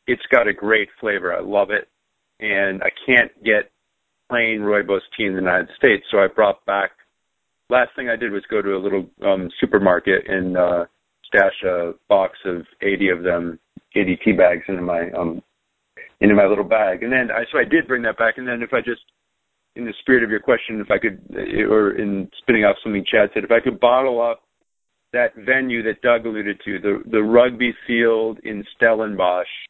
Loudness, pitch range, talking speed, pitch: -19 LUFS, 95-115 Hz, 200 wpm, 110 Hz